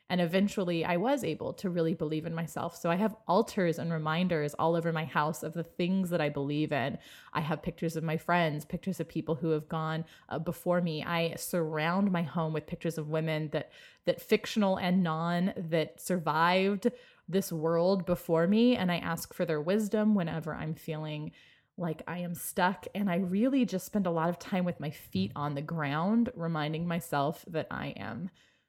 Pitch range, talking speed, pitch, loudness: 160-180 Hz, 195 wpm, 170 Hz, -31 LUFS